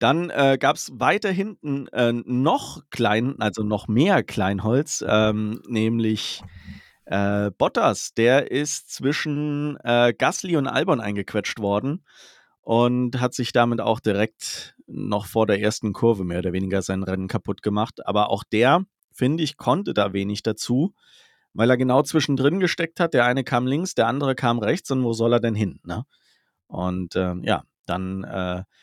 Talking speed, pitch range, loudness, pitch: 165 wpm, 105-135 Hz, -22 LUFS, 115 Hz